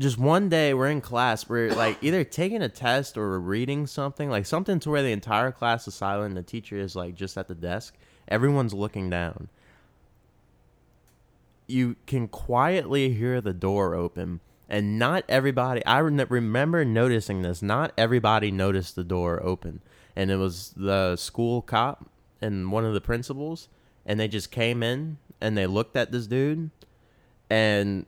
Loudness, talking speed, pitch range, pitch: -26 LUFS, 170 wpm, 100-135 Hz, 115 Hz